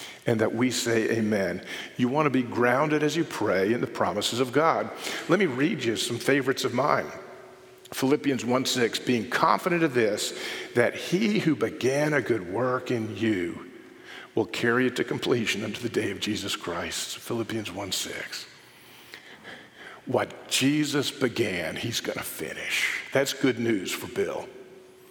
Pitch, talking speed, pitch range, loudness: 130 Hz, 165 wpm, 120-150 Hz, -26 LUFS